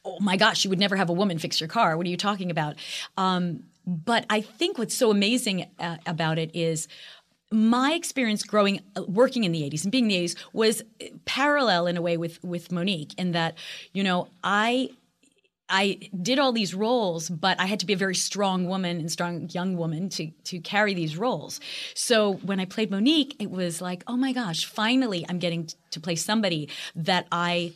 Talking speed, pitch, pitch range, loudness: 210 wpm, 190 Hz, 175-215 Hz, -25 LUFS